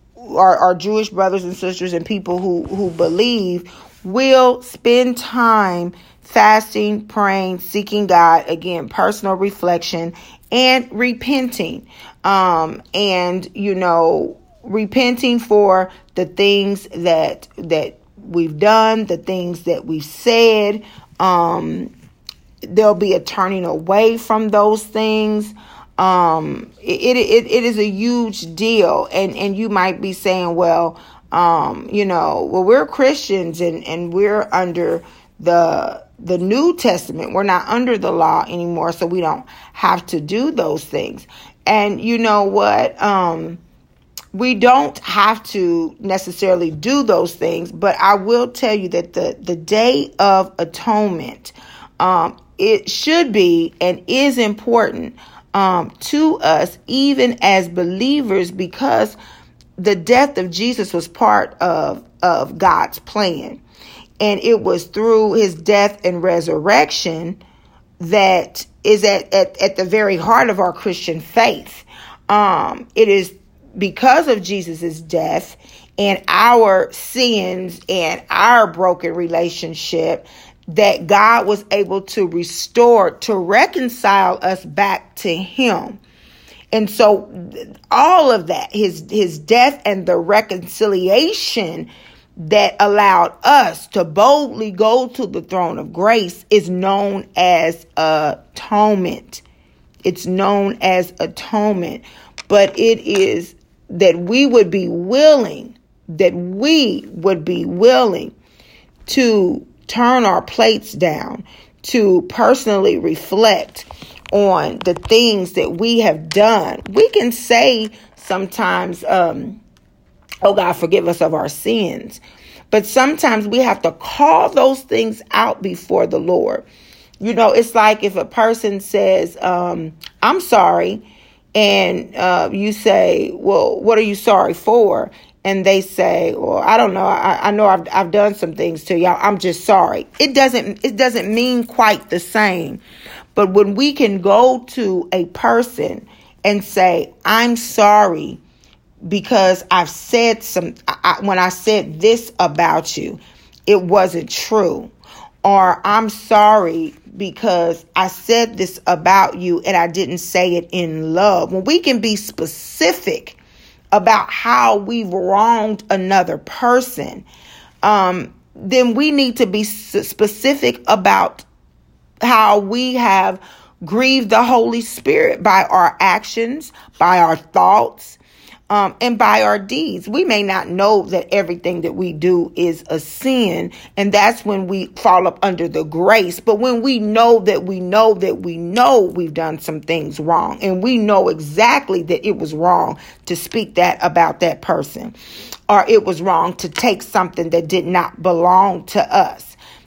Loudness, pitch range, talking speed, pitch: -15 LUFS, 180-230 Hz, 140 wpm, 200 Hz